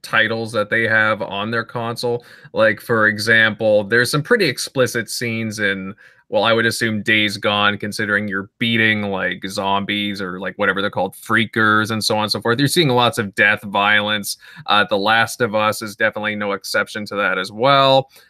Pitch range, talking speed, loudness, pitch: 105-115 Hz, 190 wpm, -17 LUFS, 110 Hz